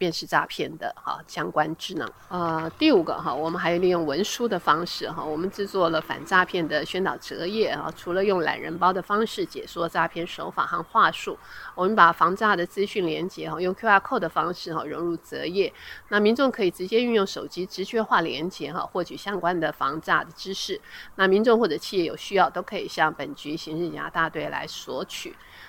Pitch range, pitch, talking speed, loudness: 165-205 Hz, 180 Hz, 320 characters per minute, -25 LUFS